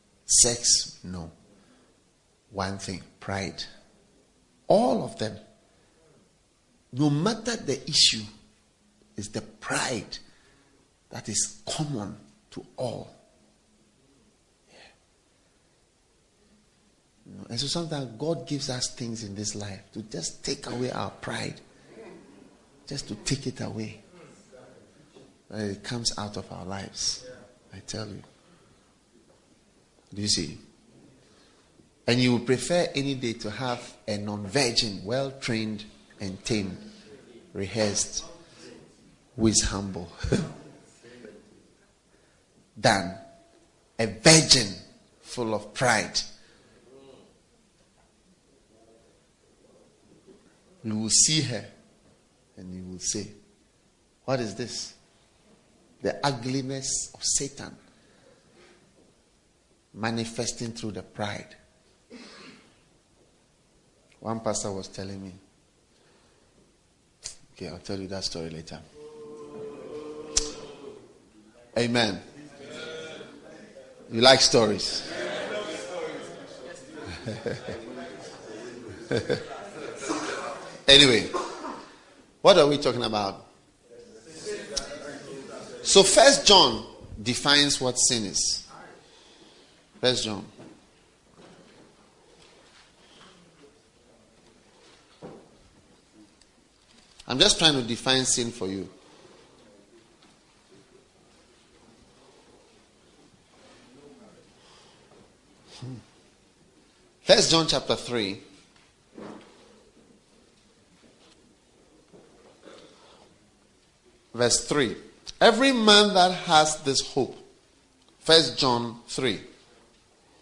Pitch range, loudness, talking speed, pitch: 105-140 Hz, -24 LUFS, 75 wpm, 120 Hz